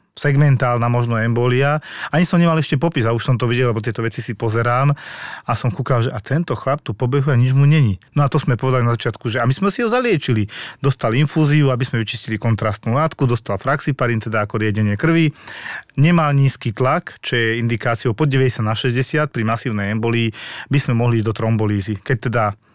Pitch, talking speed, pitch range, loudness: 125 Hz, 205 wpm, 115-140 Hz, -17 LUFS